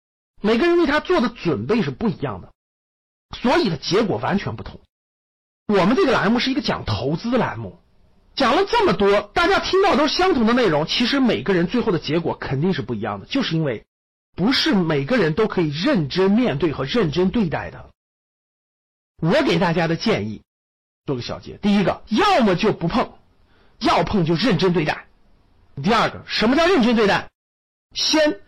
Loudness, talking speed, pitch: -19 LUFS, 270 characters per minute, 190 Hz